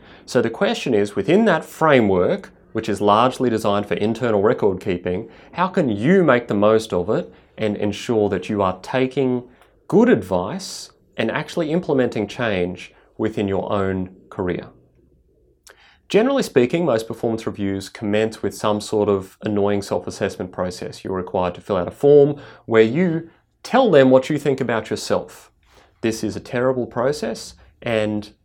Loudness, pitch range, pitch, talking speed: -20 LUFS, 100-130 Hz, 110 Hz, 160 wpm